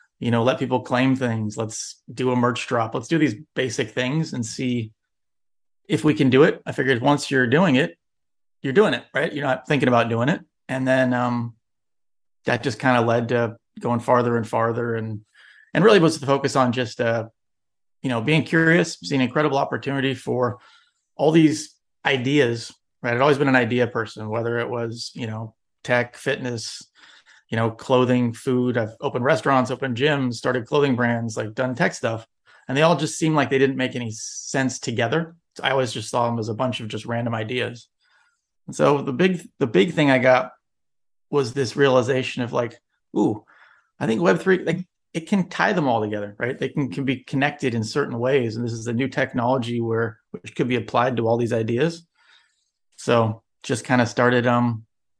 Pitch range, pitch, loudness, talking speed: 115-140 Hz, 125 Hz, -22 LUFS, 200 wpm